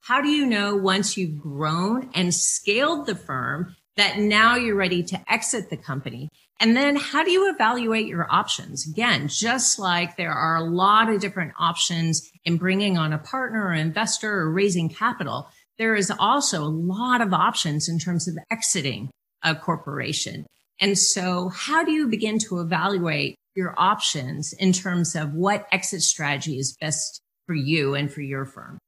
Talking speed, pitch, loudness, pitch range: 175 wpm, 180 Hz, -22 LUFS, 160-220 Hz